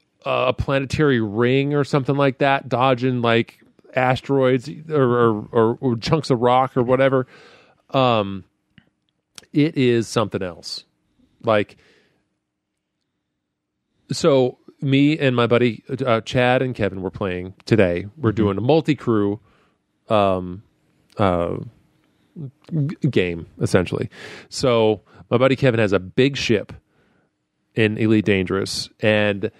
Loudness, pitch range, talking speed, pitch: -20 LUFS, 105-135 Hz, 120 wpm, 120 Hz